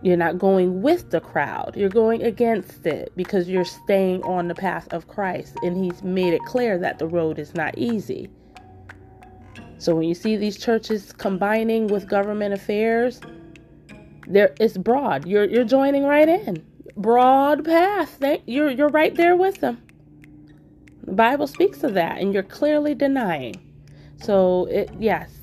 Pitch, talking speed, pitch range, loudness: 200 Hz, 160 wpm, 170-245 Hz, -21 LUFS